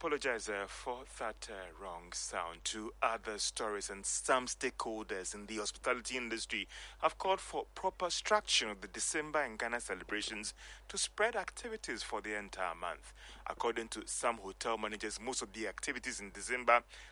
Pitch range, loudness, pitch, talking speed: 105-140 Hz, -37 LUFS, 115 Hz, 160 wpm